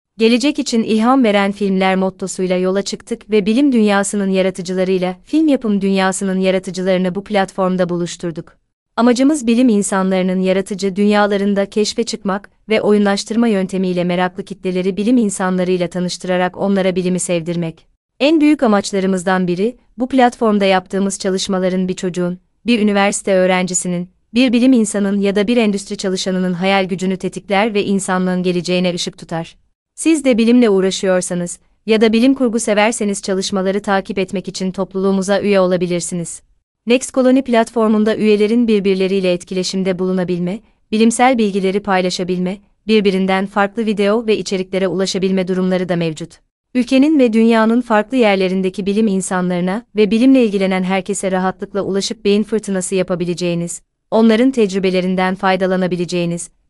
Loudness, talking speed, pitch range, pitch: -16 LUFS, 125 wpm, 185-215 Hz, 195 Hz